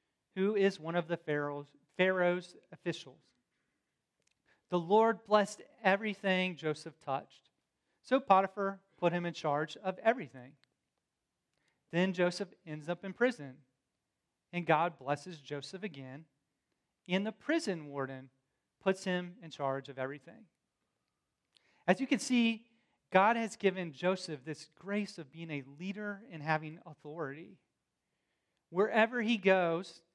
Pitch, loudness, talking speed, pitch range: 175 Hz, -34 LUFS, 125 wpm, 145-195 Hz